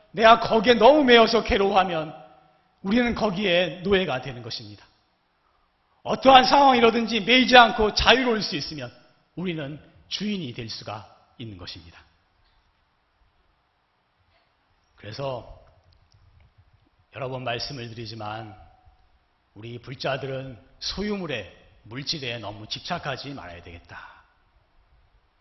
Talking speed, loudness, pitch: 250 characters per minute, -21 LUFS, 135 Hz